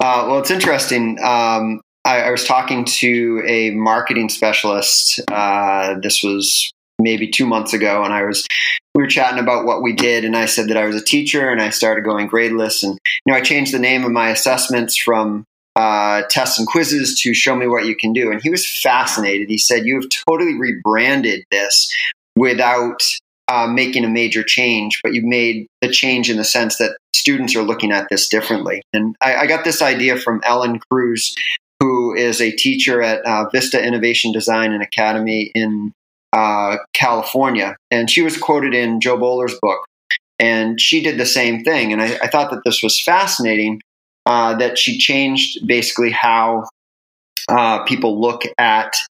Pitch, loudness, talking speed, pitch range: 115 Hz, -15 LUFS, 185 wpm, 110-125 Hz